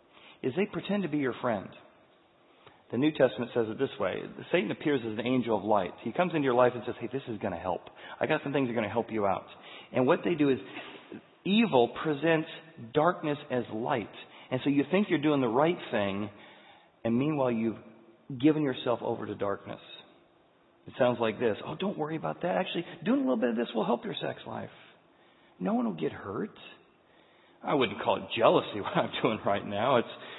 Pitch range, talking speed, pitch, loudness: 115-155 Hz, 215 wpm, 130 Hz, -30 LUFS